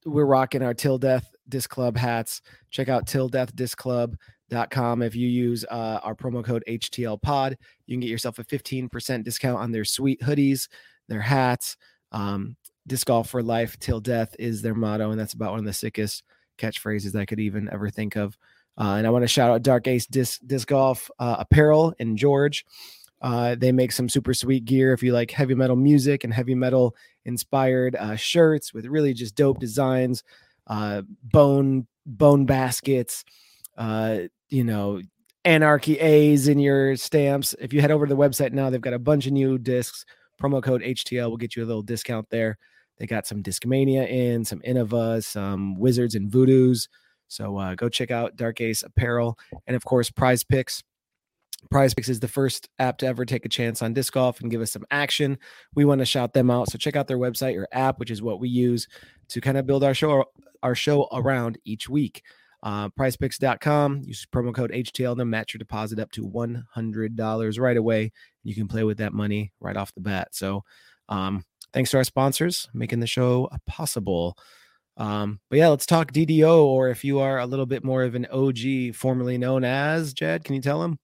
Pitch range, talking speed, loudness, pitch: 115-135 Hz, 195 wpm, -23 LUFS, 125 Hz